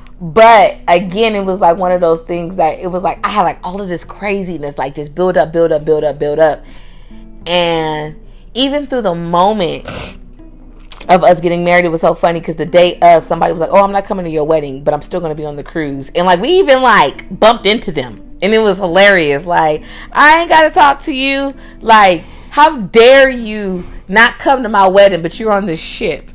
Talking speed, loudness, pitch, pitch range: 225 wpm, -11 LUFS, 175 Hz, 155-205 Hz